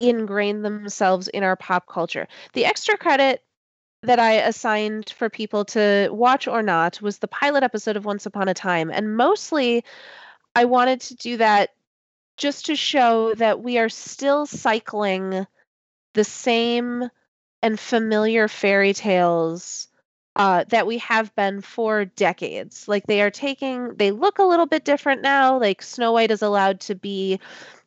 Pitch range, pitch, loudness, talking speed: 205-250 Hz, 220 Hz, -21 LUFS, 155 wpm